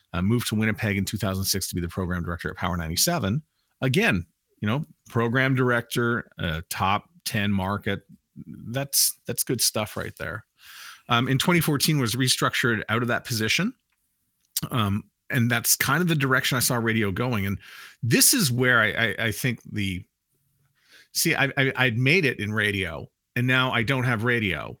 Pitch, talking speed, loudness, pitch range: 120 Hz, 175 wpm, -24 LUFS, 100-130 Hz